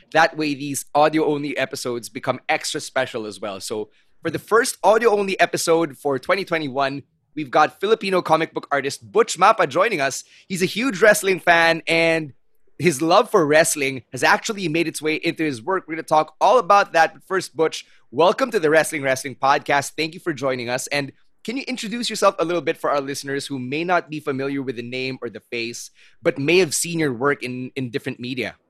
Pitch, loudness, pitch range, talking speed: 155 Hz, -20 LUFS, 140-175 Hz, 210 wpm